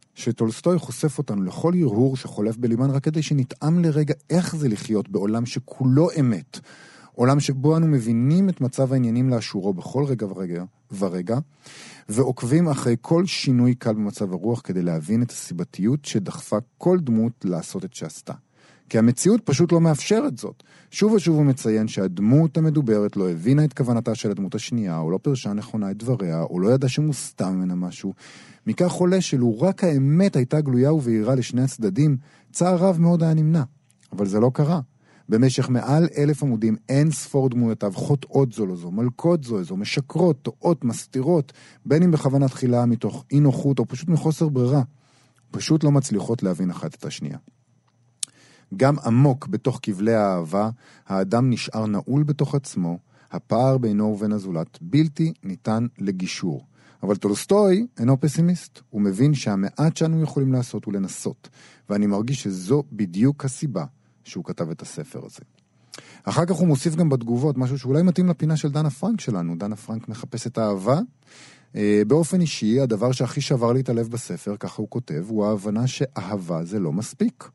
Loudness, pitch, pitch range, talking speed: -22 LUFS, 130 Hz, 110-150 Hz, 160 wpm